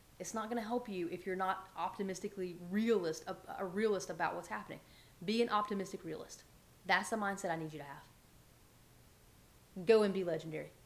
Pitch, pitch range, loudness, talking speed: 190 Hz, 175-210 Hz, -37 LUFS, 175 wpm